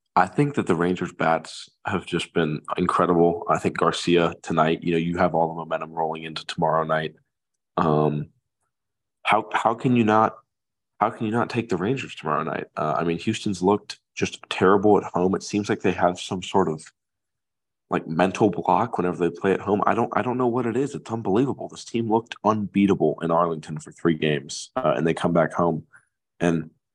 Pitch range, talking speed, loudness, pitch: 80-110 Hz, 205 wpm, -23 LUFS, 90 Hz